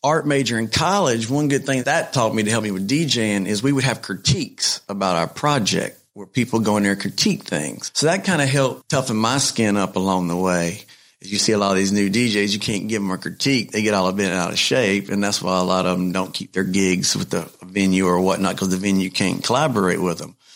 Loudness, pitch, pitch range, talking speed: -20 LUFS, 100 Hz, 95-120 Hz, 260 wpm